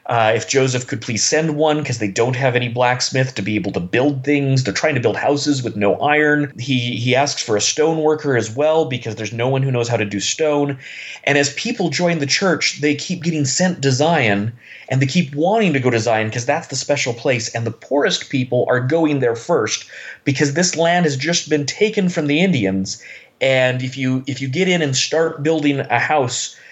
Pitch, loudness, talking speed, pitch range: 135 Hz, -18 LUFS, 225 wpm, 125-155 Hz